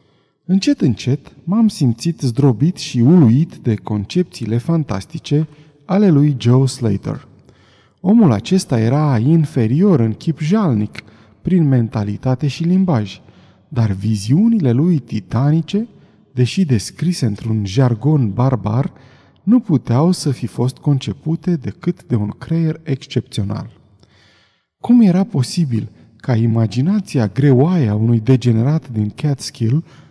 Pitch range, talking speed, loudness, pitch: 115-160 Hz, 110 wpm, -16 LUFS, 135 Hz